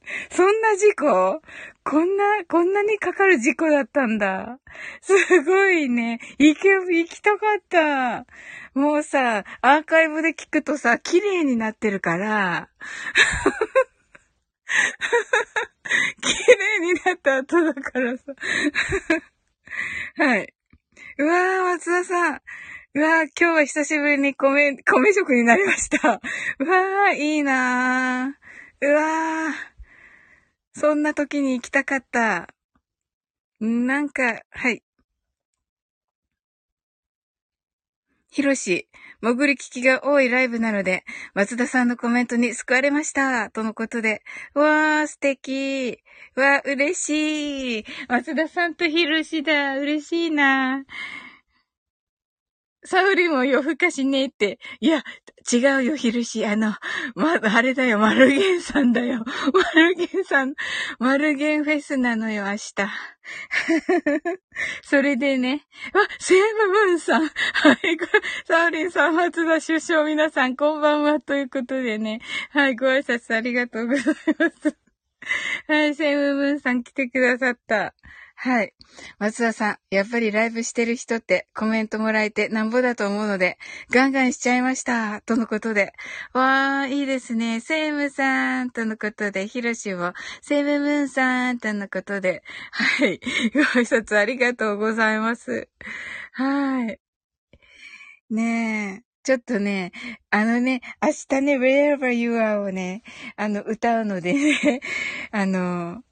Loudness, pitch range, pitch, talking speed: -21 LUFS, 235-315 Hz, 275 Hz, 250 characters per minute